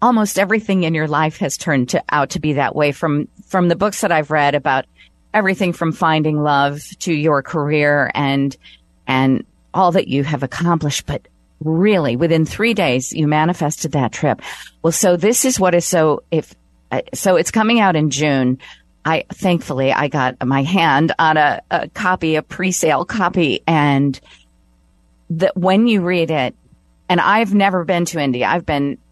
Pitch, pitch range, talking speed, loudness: 160 Hz, 145-185 Hz, 175 wpm, -16 LUFS